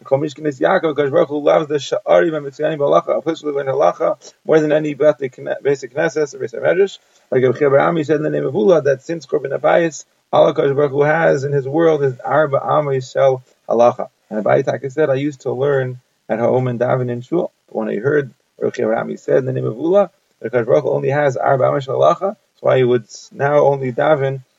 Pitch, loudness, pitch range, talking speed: 145 Hz, -17 LUFS, 135-160 Hz, 210 wpm